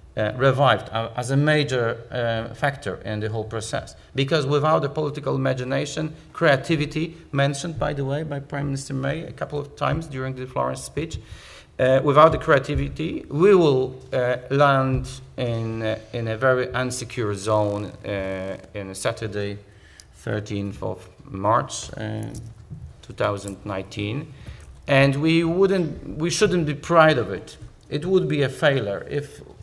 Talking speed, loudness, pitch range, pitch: 140 wpm, -23 LUFS, 110-145 Hz, 130 Hz